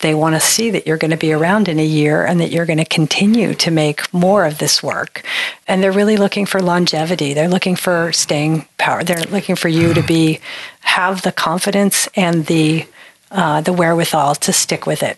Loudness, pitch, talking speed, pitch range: -15 LUFS, 170 Hz, 215 wpm, 160-195 Hz